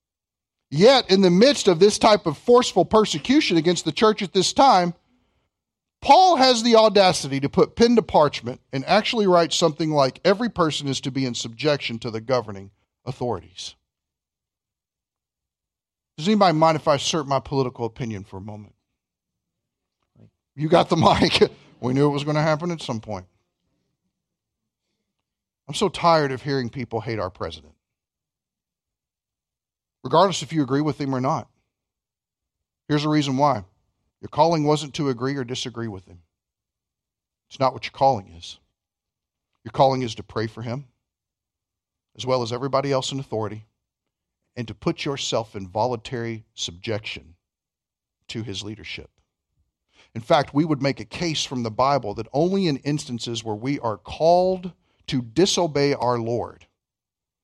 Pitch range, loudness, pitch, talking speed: 110-160 Hz, -21 LUFS, 135 Hz, 155 wpm